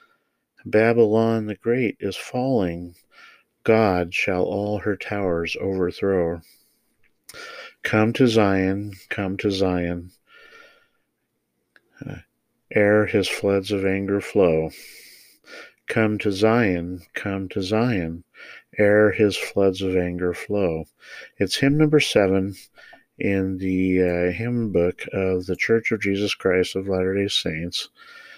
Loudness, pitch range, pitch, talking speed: -22 LUFS, 90-110 Hz, 100 Hz, 115 wpm